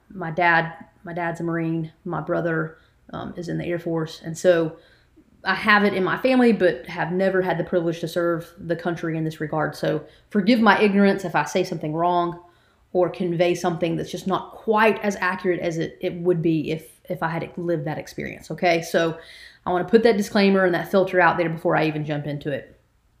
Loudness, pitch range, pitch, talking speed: -22 LUFS, 165-185 Hz, 175 Hz, 215 wpm